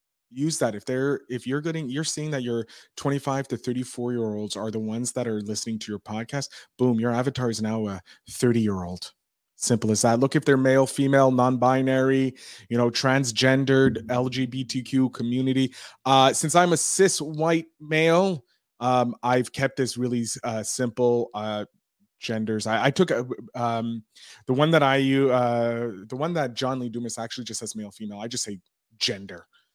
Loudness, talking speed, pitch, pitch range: -24 LUFS, 185 wpm, 125 Hz, 115-135 Hz